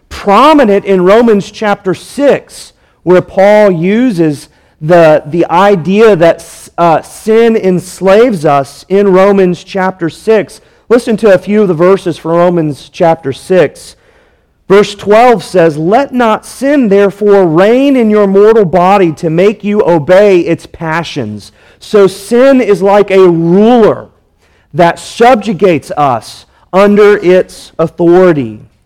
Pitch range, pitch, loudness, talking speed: 165-210 Hz, 190 Hz, -8 LUFS, 125 wpm